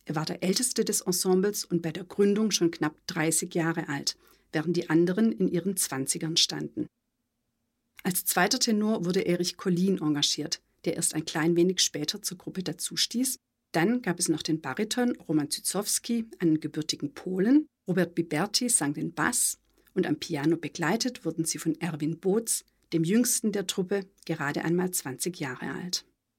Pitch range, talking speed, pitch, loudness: 160-200 Hz, 165 wpm, 175 Hz, -28 LUFS